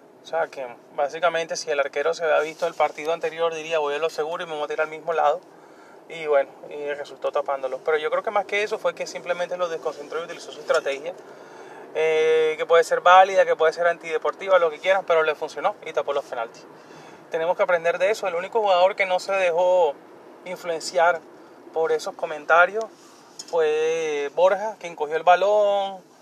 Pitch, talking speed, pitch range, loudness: 175 Hz, 200 wpm, 155-200 Hz, -23 LUFS